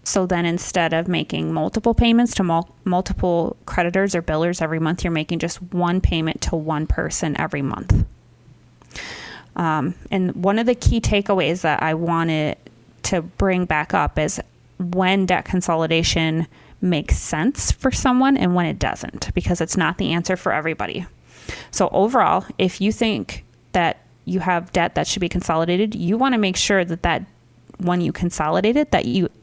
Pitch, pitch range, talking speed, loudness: 175 Hz, 165-190 Hz, 170 wpm, -20 LUFS